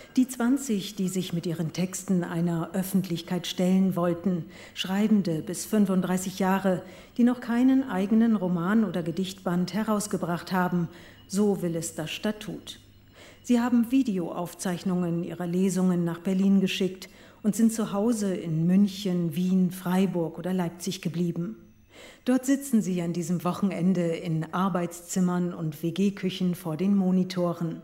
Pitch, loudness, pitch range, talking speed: 185 Hz, -27 LUFS, 175-200 Hz, 130 wpm